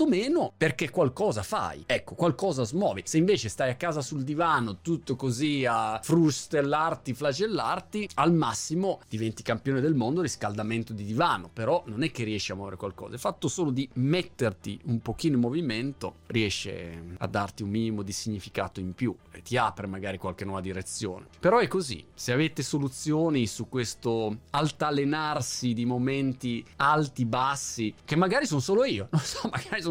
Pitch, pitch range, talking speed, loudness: 125 Hz, 110-150 Hz, 165 wpm, -28 LUFS